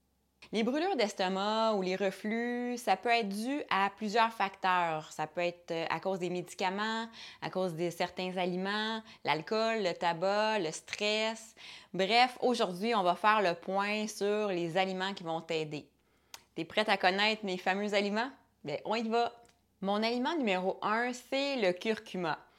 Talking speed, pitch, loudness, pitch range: 160 wpm, 200 Hz, -32 LUFS, 180-225 Hz